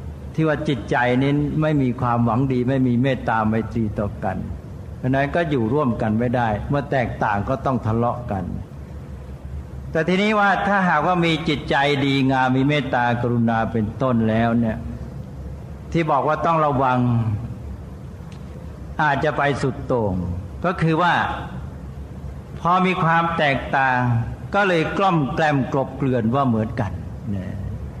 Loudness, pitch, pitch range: -20 LUFS, 125 Hz, 110-150 Hz